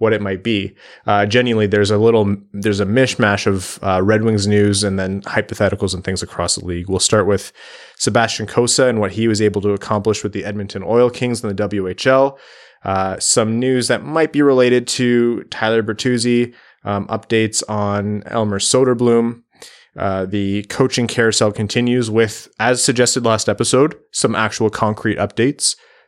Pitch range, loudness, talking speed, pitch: 100-120 Hz, -16 LUFS, 170 wpm, 110 Hz